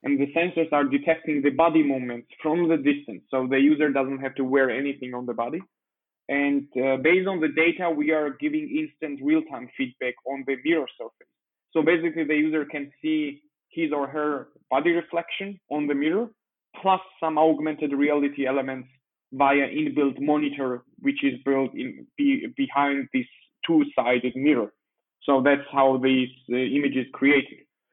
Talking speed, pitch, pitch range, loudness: 165 wpm, 150 Hz, 135-170 Hz, -24 LUFS